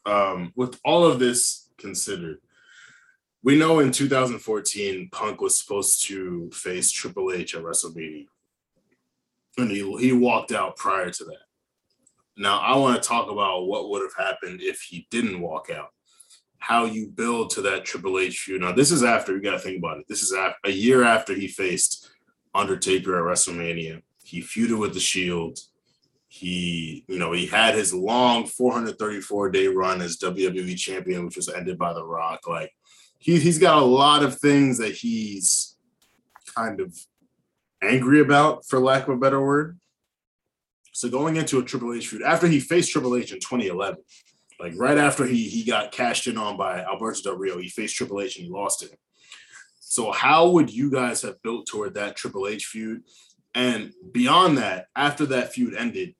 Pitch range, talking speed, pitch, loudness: 95-155 Hz, 180 wpm, 125 Hz, -22 LUFS